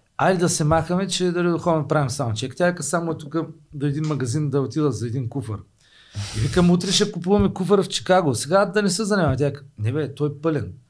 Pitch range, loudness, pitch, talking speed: 135-180 Hz, -22 LUFS, 155 Hz, 240 wpm